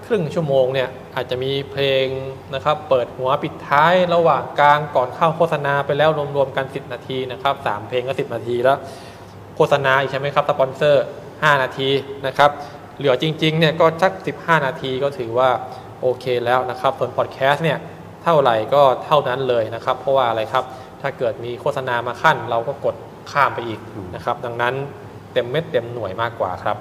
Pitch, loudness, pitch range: 135 Hz, -19 LUFS, 125-145 Hz